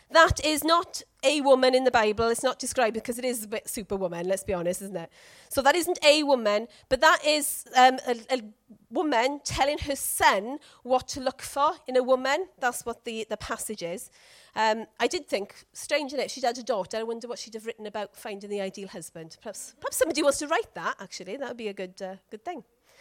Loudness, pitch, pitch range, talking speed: -26 LUFS, 245 Hz, 215-280 Hz, 230 wpm